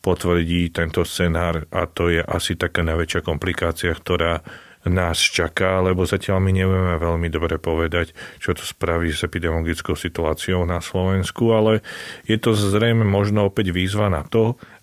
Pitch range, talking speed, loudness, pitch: 85-95 Hz, 150 wpm, -21 LUFS, 90 Hz